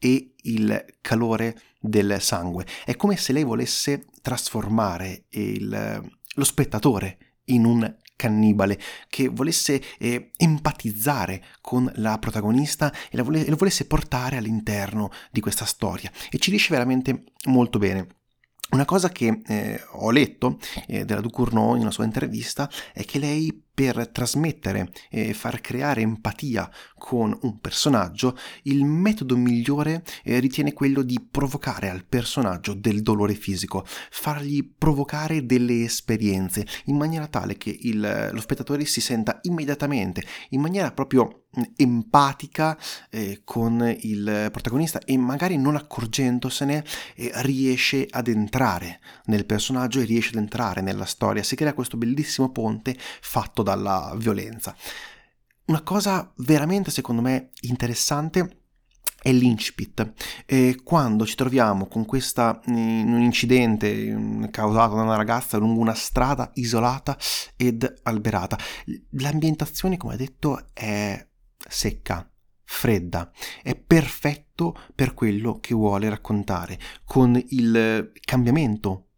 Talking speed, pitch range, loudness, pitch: 125 wpm, 110-140 Hz, -24 LUFS, 120 Hz